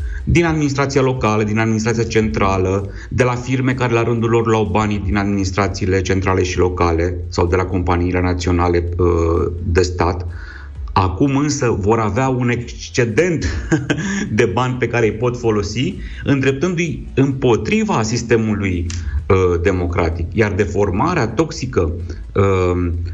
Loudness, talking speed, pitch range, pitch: -17 LUFS, 120 wpm, 90-120 Hz, 105 Hz